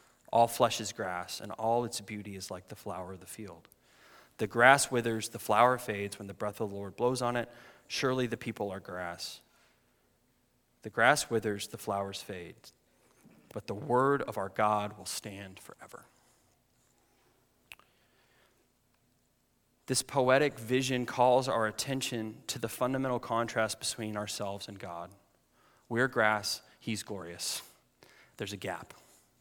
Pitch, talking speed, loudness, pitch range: 110 Hz, 145 wpm, -32 LUFS, 100-120 Hz